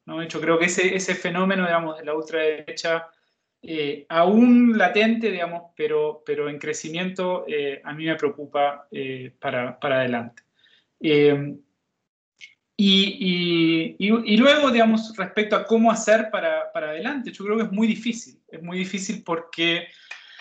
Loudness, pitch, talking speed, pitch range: -22 LUFS, 180 Hz, 150 wpm, 155-220 Hz